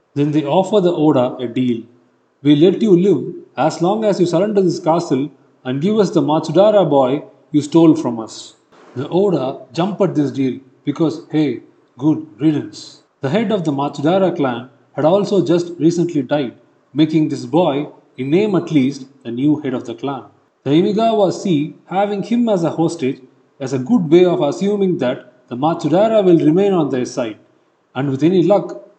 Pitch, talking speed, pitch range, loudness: 155 Hz, 180 wpm, 135-180 Hz, -16 LUFS